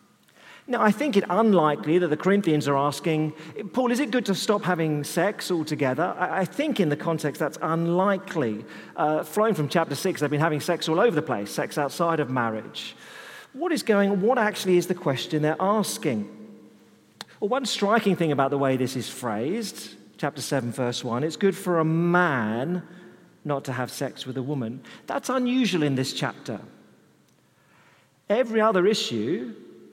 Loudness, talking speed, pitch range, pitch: -25 LUFS, 175 wpm, 140-200 Hz, 165 Hz